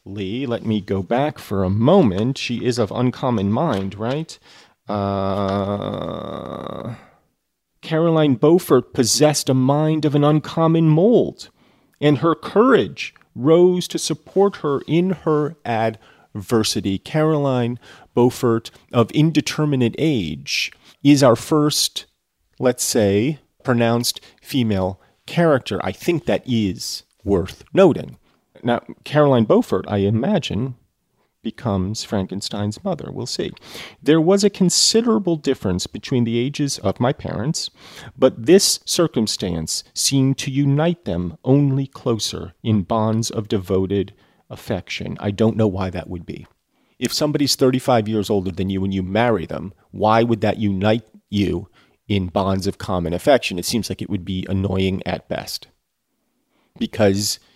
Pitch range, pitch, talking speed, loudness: 100-145 Hz, 115 Hz, 130 wpm, -19 LUFS